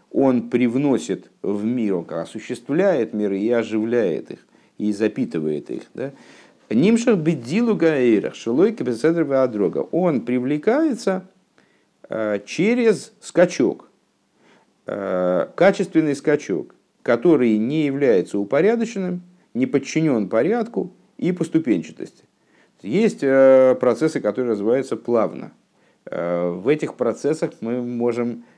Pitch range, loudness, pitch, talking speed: 110-165 Hz, -20 LUFS, 130 Hz, 90 wpm